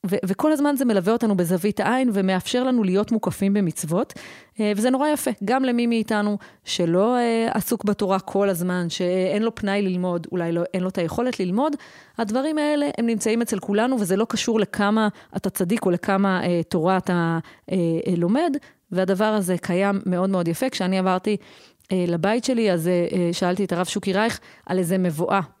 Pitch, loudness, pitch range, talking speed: 200 Hz, -22 LUFS, 180-230 Hz, 165 wpm